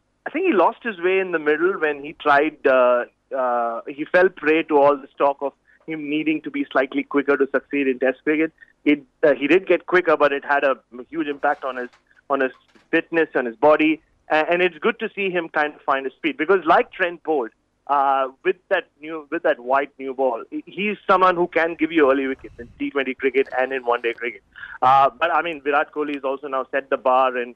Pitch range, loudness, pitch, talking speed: 135-165 Hz, -21 LUFS, 145 Hz, 235 wpm